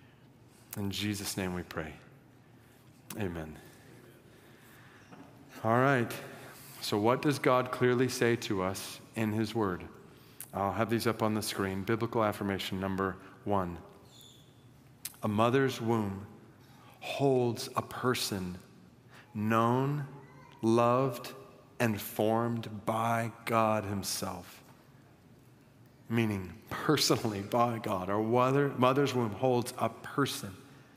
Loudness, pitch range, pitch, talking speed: -31 LUFS, 105-130 Hz, 115 Hz, 105 wpm